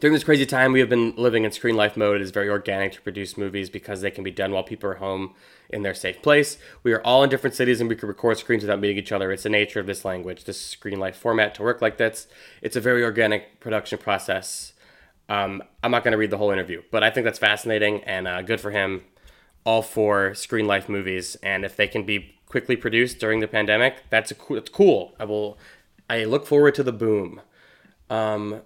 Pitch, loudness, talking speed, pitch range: 105 Hz, -23 LUFS, 240 wpm, 100-115 Hz